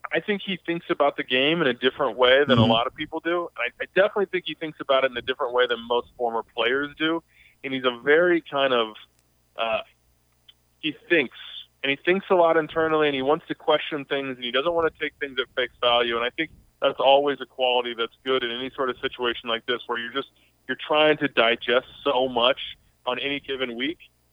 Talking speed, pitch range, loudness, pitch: 235 wpm, 120-155 Hz, -24 LUFS, 135 Hz